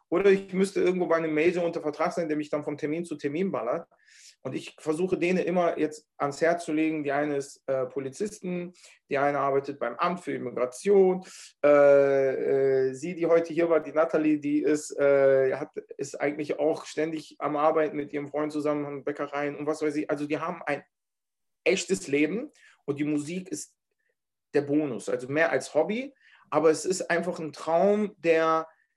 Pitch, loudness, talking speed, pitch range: 155 Hz, -27 LUFS, 190 wpm, 145-175 Hz